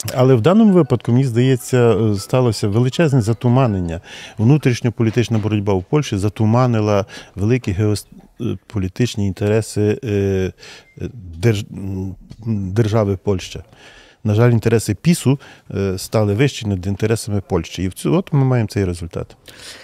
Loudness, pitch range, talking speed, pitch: -17 LUFS, 100-125 Hz, 105 wpm, 110 Hz